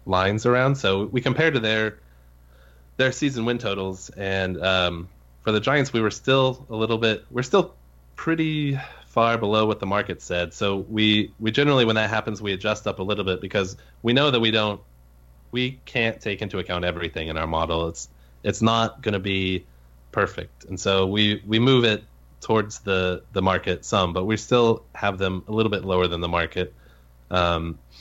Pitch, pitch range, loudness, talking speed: 100 Hz, 85-115 Hz, -23 LUFS, 195 wpm